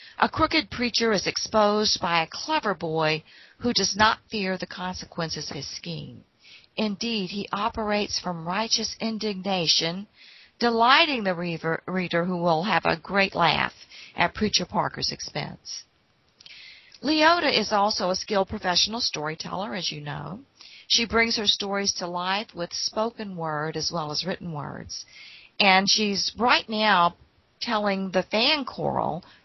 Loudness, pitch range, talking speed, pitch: -24 LUFS, 170-220 Hz, 140 wpm, 195 Hz